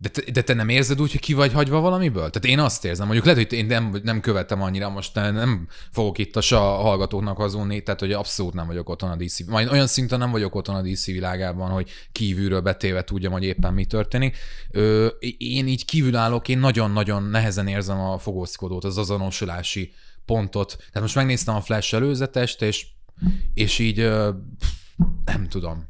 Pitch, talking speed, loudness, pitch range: 105 Hz, 195 wpm, -22 LUFS, 95-120 Hz